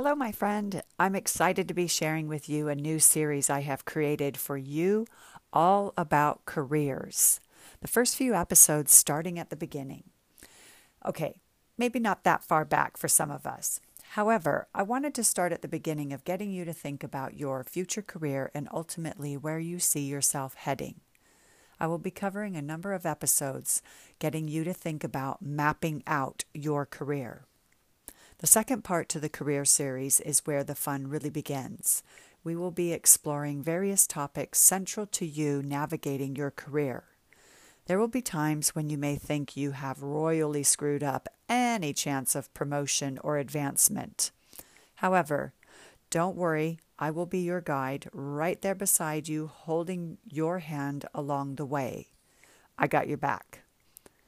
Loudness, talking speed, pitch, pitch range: -28 LUFS, 160 wpm, 155 Hz, 145-180 Hz